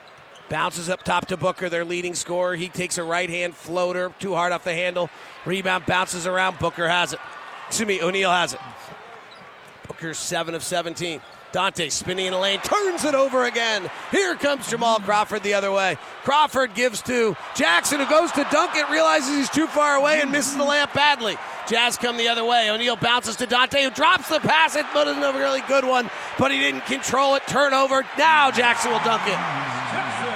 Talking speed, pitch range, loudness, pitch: 195 wpm, 180-280 Hz, -21 LUFS, 225 Hz